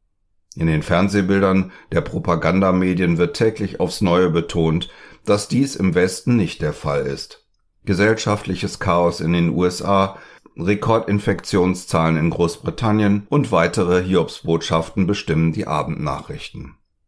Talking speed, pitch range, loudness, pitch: 110 wpm, 85-100 Hz, -19 LUFS, 95 Hz